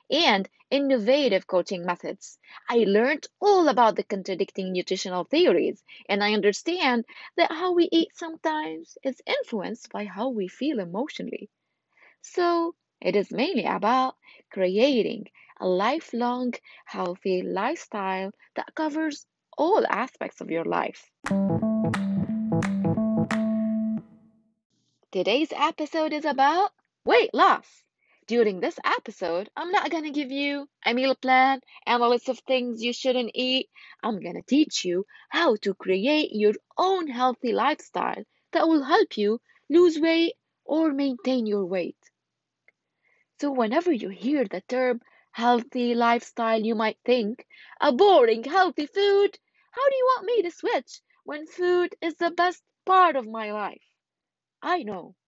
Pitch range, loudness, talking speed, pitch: 215-325 Hz, -25 LUFS, 135 wpm, 255 Hz